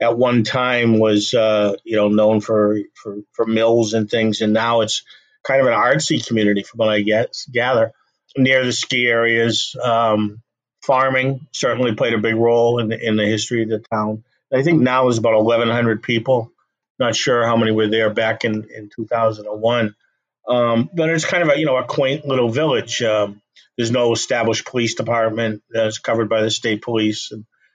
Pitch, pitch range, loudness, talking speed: 115 Hz, 110-120 Hz, -18 LUFS, 190 wpm